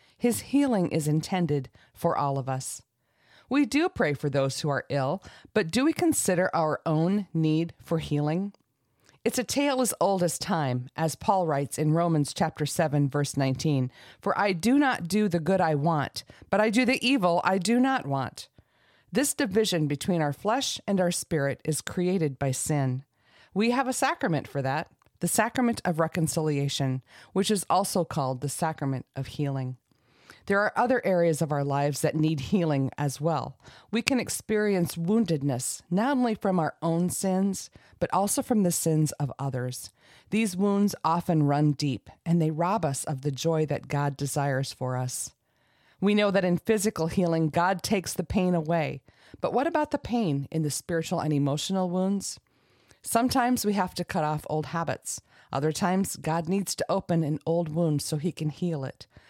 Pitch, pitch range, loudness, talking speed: 165 Hz, 140-195 Hz, -27 LUFS, 180 wpm